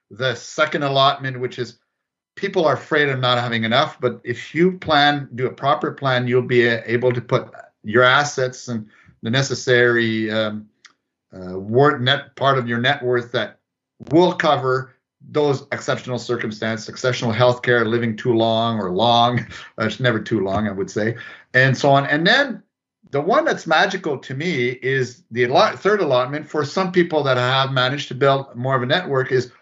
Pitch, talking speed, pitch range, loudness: 125 Hz, 180 wpm, 120-140 Hz, -19 LUFS